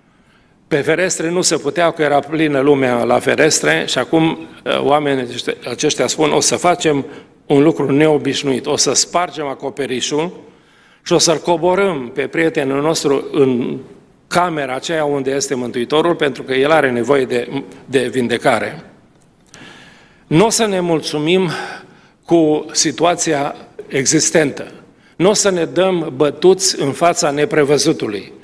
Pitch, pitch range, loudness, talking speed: 150 Hz, 140-170 Hz, -15 LUFS, 135 wpm